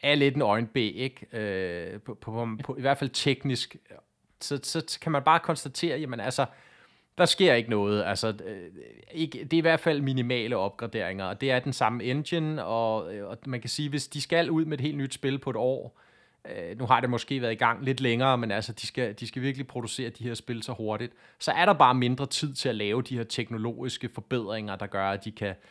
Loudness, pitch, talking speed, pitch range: -28 LUFS, 125 Hz, 230 wpm, 115-140 Hz